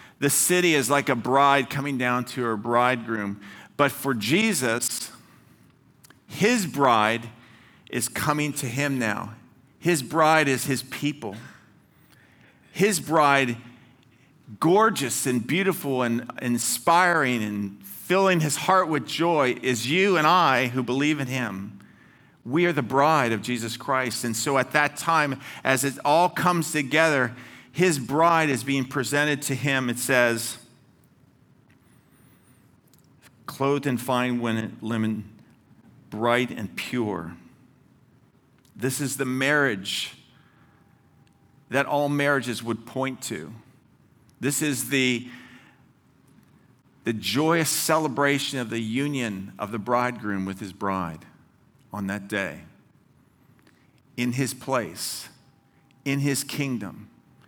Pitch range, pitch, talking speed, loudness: 120-145 Hz, 130 Hz, 120 wpm, -24 LUFS